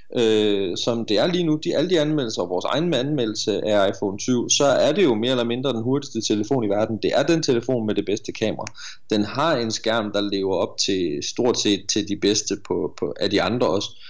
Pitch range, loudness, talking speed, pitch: 105-130 Hz, -22 LUFS, 240 wpm, 115 Hz